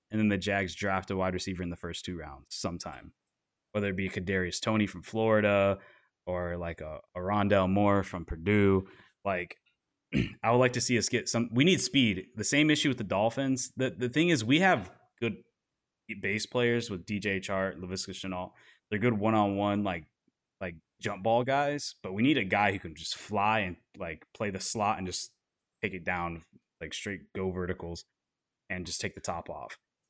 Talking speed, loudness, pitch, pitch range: 195 wpm, -30 LUFS, 100 Hz, 90-110 Hz